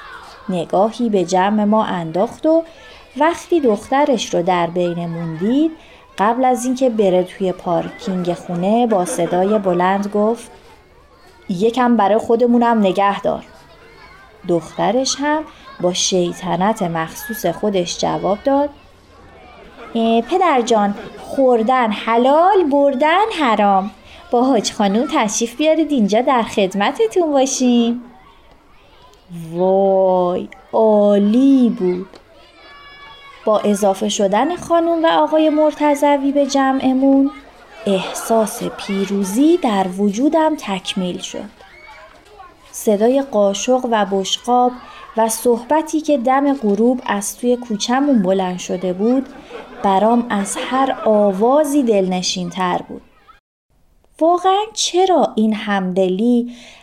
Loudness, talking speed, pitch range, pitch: -16 LUFS, 100 wpm, 195-275 Hz, 230 Hz